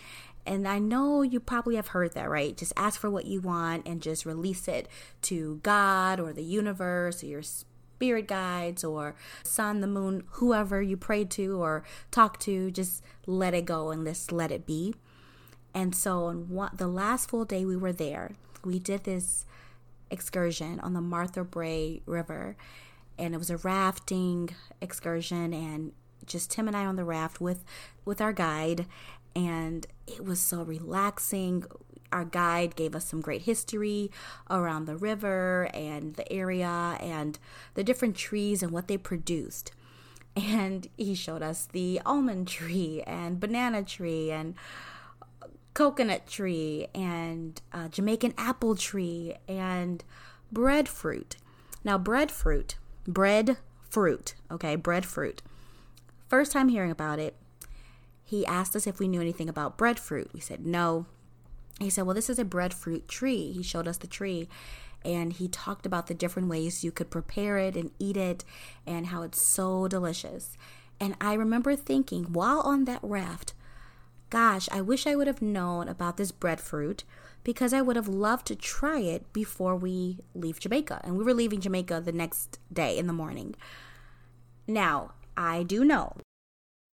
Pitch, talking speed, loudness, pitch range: 180 Hz, 160 wpm, -30 LUFS, 165-200 Hz